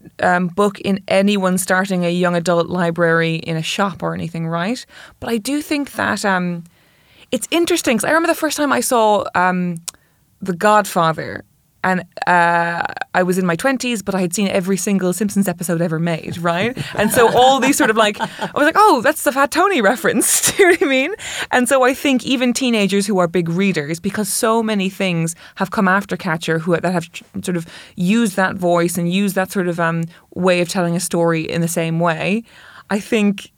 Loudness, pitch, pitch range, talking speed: -17 LUFS, 190 Hz, 170-230 Hz, 210 wpm